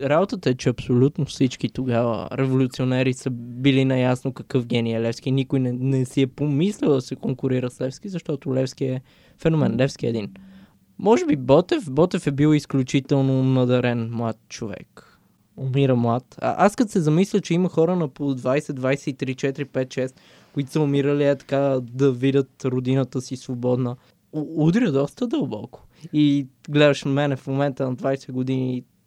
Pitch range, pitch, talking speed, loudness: 130-145 Hz, 135 Hz, 165 wpm, -22 LUFS